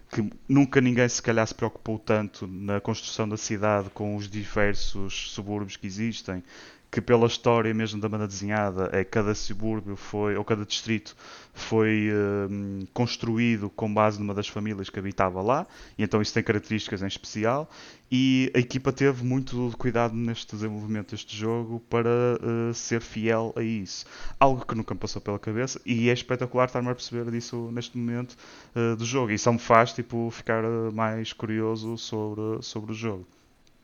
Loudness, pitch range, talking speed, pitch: -27 LUFS, 105-120 Hz, 175 wpm, 110 Hz